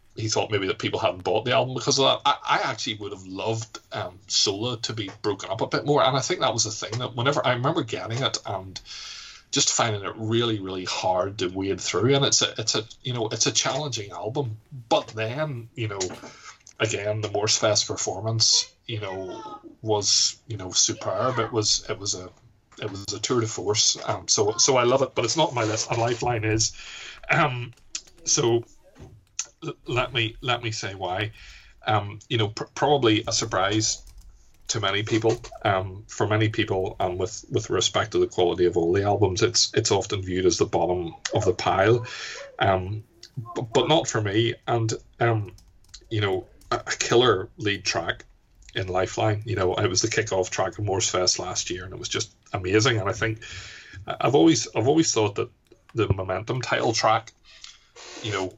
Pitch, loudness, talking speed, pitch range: 110 Hz, -24 LUFS, 200 wpm, 105-120 Hz